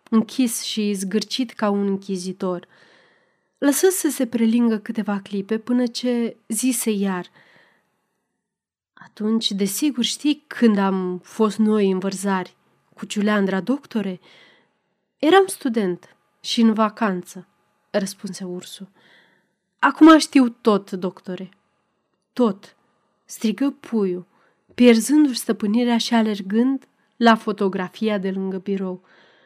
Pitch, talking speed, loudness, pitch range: 215 Hz, 105 wpm, -20 LUFS, 195-235 Hz